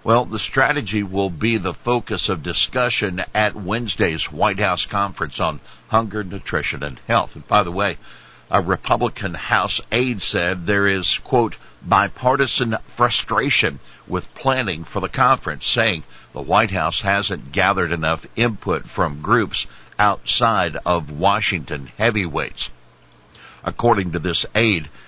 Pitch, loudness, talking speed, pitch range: 100 Hz, -20 LUFS, 135 wpm, 90-115 Hz